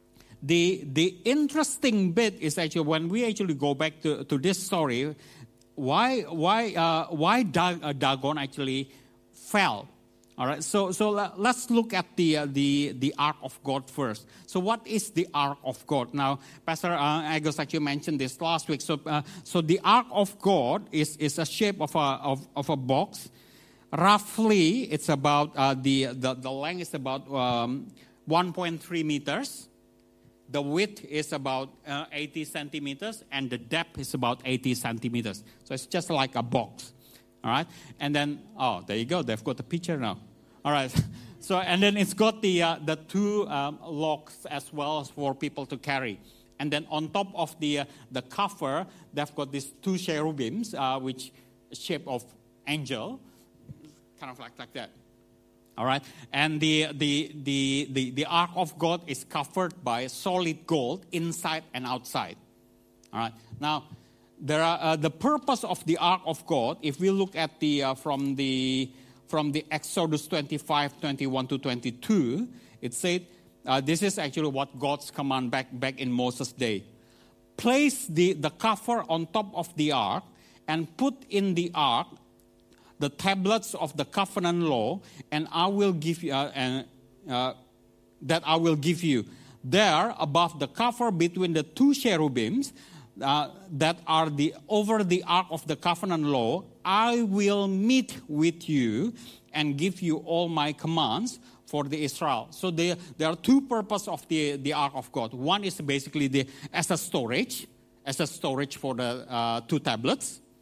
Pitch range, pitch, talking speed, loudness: 135-175 Hz, 150 Hz, 170 wpm, -28 LUFS